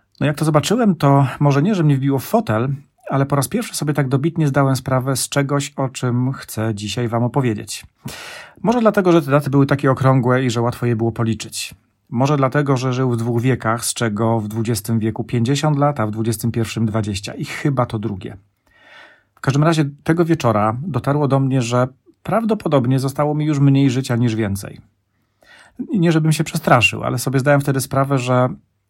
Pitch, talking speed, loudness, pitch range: 135 Hz, 190 wpm, -18 LUFS, 115-145 Hz